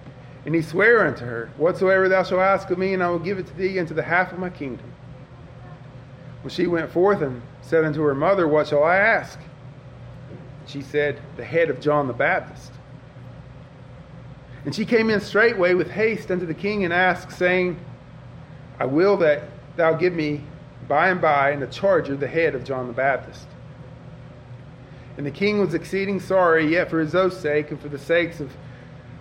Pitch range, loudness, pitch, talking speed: 135-180 Hz, -21 LUFS, 150 Hz, 195 wpm